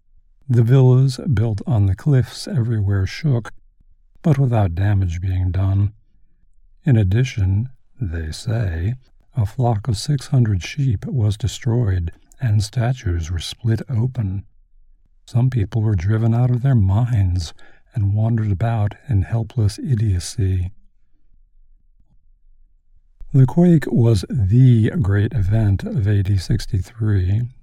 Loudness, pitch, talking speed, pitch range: -19 LUFS, 110 Hz, 115 wpm, 95-120 Hz